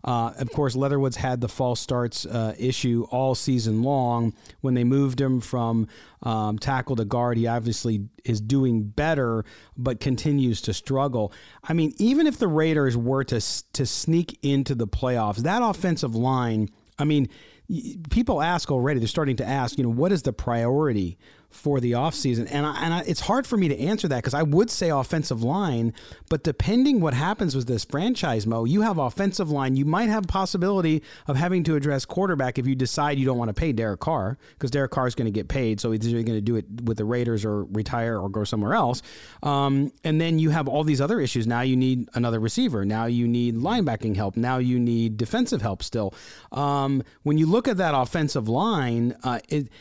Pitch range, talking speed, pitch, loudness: 115-150 Hz, 205 wpm, 130 Hz, -24 LUFS